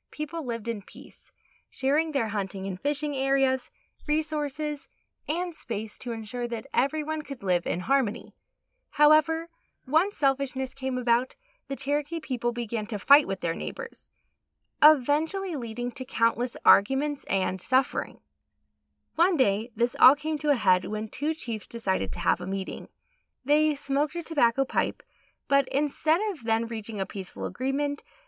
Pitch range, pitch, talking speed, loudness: 230-300 Hz, 270 Hz, 150 wpm, -27 LUFS